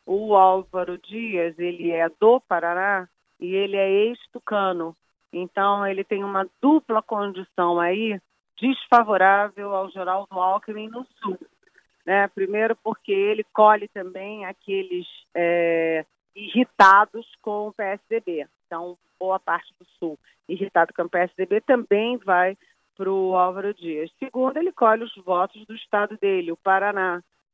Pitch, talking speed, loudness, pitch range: 195 Hz, 135 wpm, -22 LUFS, 180-215 Hz